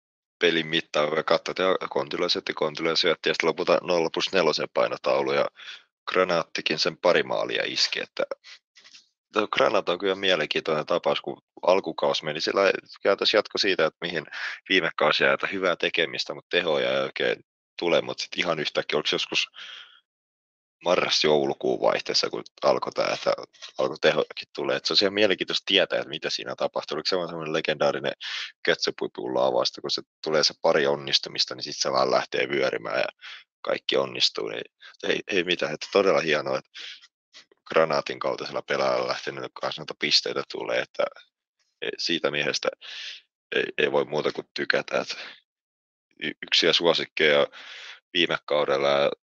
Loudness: -25 LUFS